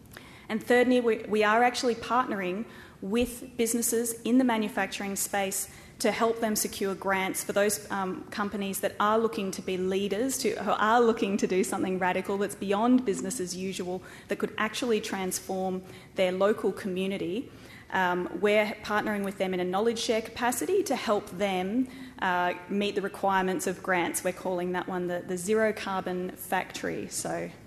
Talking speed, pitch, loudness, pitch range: 165 wpm, 205 Hz, -28 LUFS, 190-225 Hz